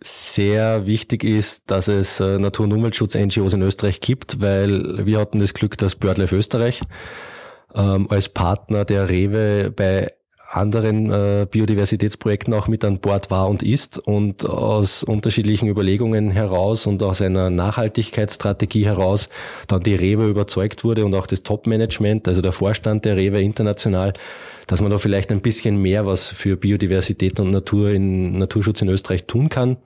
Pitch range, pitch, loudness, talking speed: 95-110 Hz, 105 Hz, -19 LUFS, 155 wpm